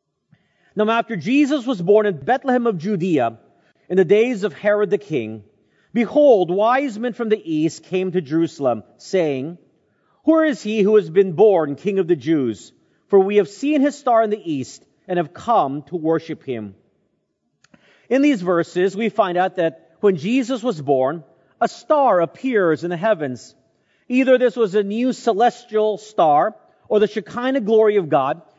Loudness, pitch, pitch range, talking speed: -19 LUFS, 205 Hz, 165-235 Hz, 170 wpm